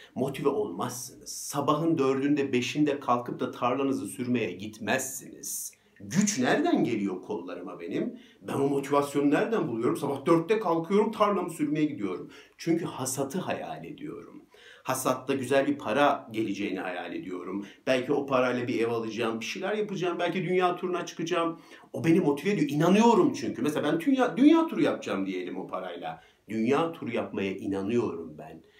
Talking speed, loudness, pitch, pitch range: 145 wpm, -28 LUFS, 145 Hz, 125-180 Hz